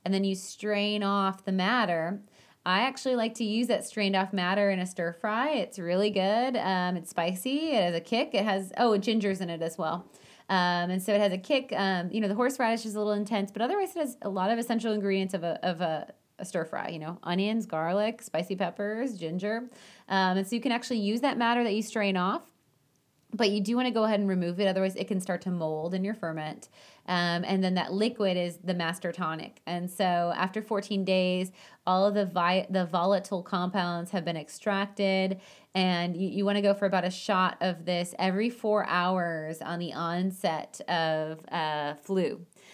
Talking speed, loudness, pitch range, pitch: 215 wpm, -29 LUFS, 175-210 Hz, 190 Hz